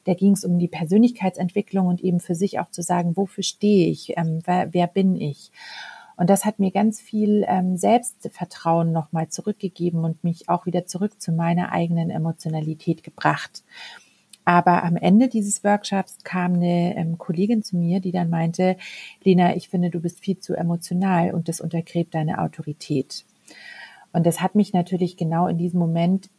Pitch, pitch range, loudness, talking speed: 180 Hz, 170-195 Hz, -22 LUFS, 175 wpm